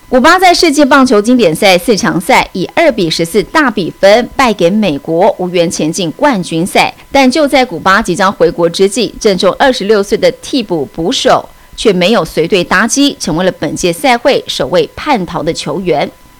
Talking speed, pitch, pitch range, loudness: 280 characters per minute, 215 Hz, 180-275 Hz, -10 LUFS